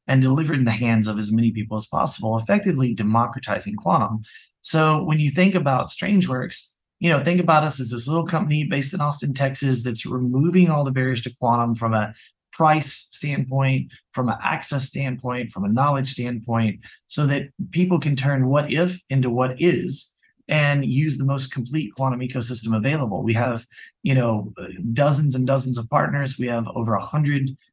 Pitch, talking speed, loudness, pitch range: 135 Hz, 180 wpm, -22 LUFS, 120-155 Hz